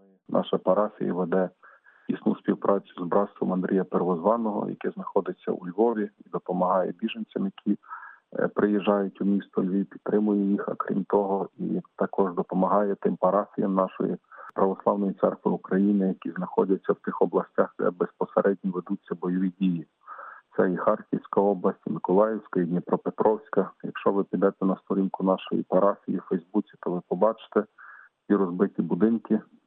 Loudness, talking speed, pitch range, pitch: -27 LUFS, 140 wpm, 95-100 Hz, 95 Hz